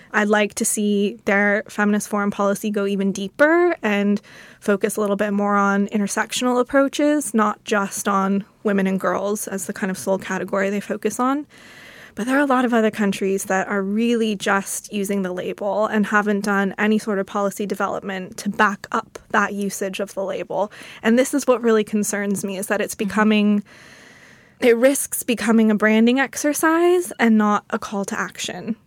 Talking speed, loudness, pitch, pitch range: 185 wpm, -20 LUFS, 210 Hz, 200-225 Hz